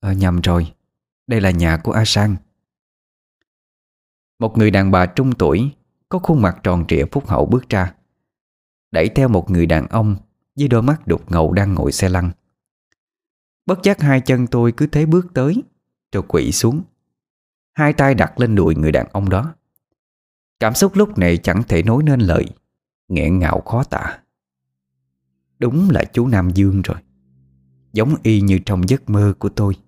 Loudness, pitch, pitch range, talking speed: -17 LUFS, 100 Hz, 80-125 Hz, 175 wpm